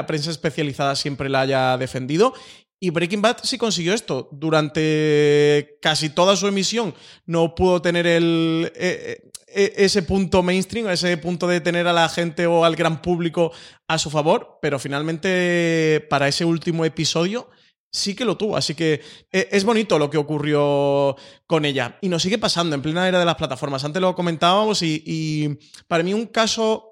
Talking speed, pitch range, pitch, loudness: 175 wpm, 150-185 Hz, 165 Hz, -20 LUFS